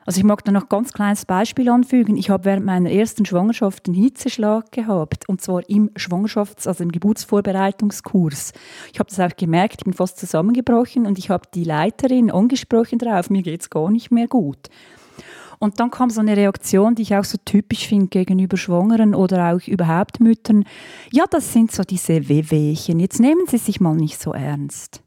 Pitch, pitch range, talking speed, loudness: 200 Hz, 180-225 Hz, 195 wpm, -18 LUFS